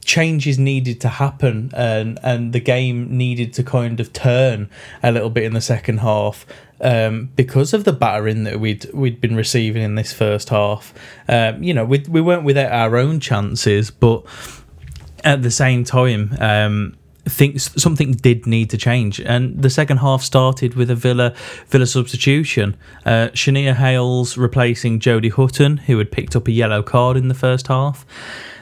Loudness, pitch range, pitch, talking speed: -17 LUFS, 115-130 Hz, 125 Hz, 170 wpm